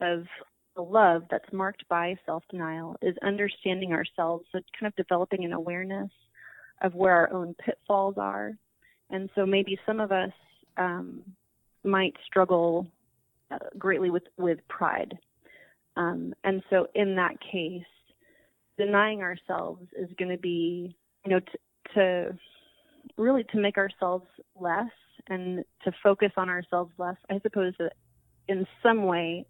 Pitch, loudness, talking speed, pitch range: 185 Hz, -28 LUFS, 140 wpm, 175-195 Hz